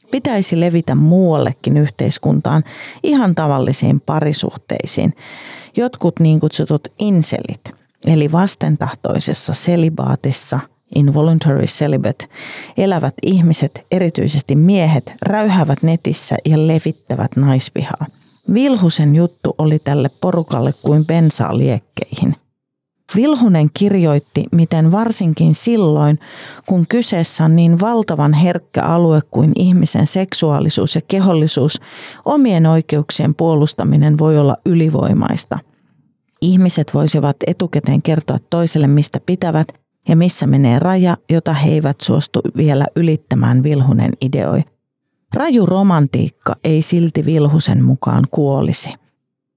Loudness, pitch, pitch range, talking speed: -14 LUFS, 155 Hz, 145-175 Hz, 100 wpm